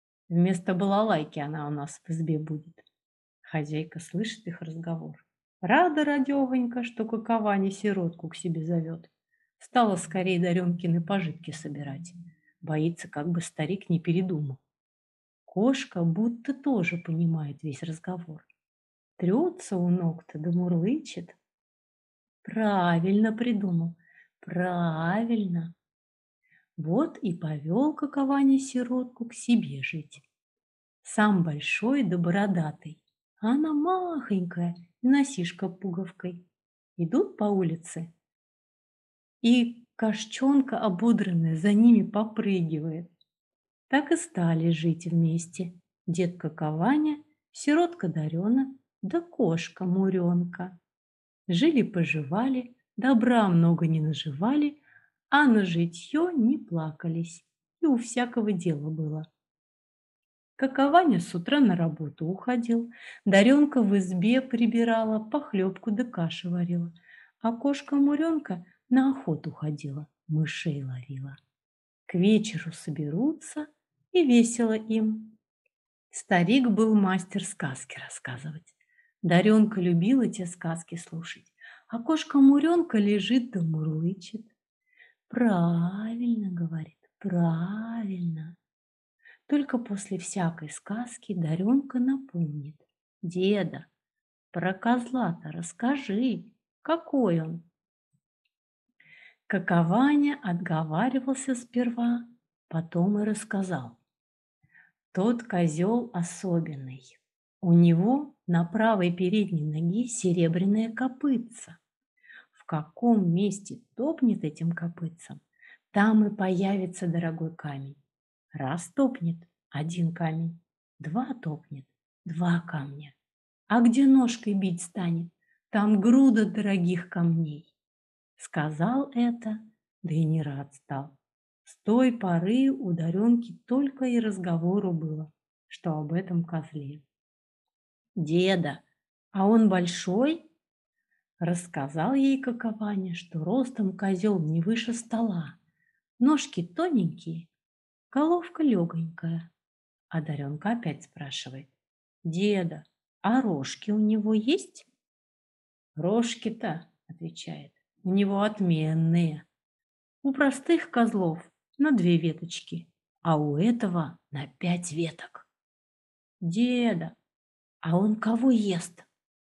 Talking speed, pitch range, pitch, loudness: 95 wpm, 165-235 Hz, 185 Hz, -27 LUFS